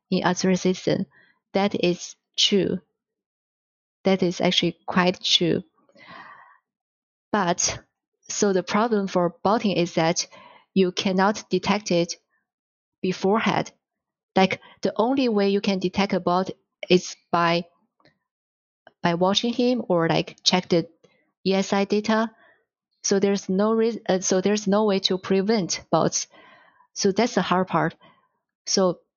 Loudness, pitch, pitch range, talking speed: -23 LUFS, 195 Hz, 180-210 Hz, 125 wpm